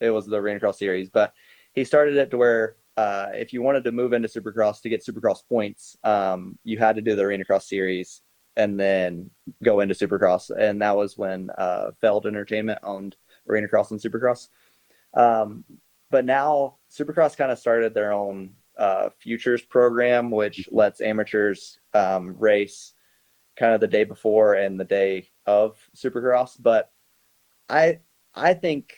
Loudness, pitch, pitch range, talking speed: -23 LUFS, 110 Hz, 100-120 Hz, 170 wpm